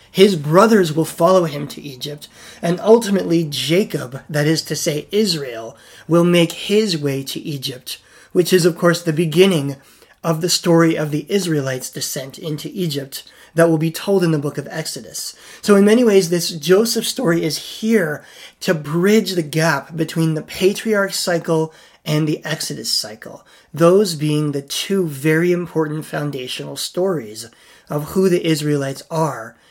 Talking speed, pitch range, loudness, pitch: 160 wpm, 150-180 Hz, -18 LUFS, 165 Hz